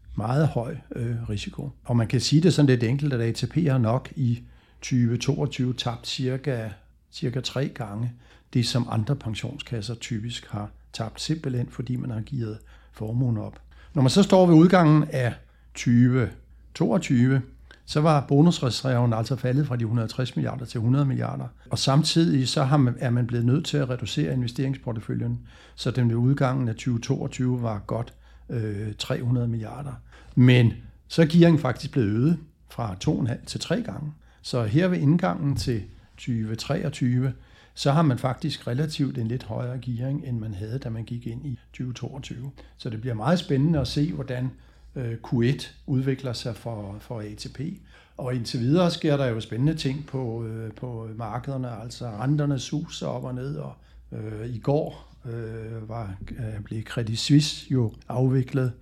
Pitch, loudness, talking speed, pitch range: 125 Hz, -25 LUFS, 160 wpm, 115-140 Hz